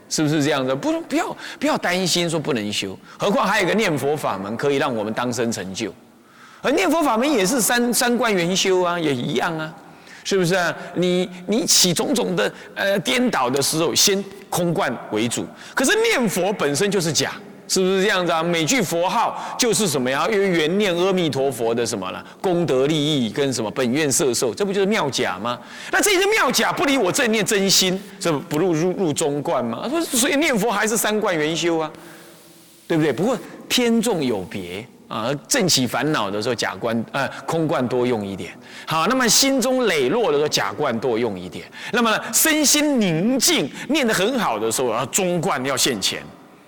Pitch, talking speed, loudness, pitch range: 180 Hz, 285 characters per minute, -20 LUFS, 145-220 Hz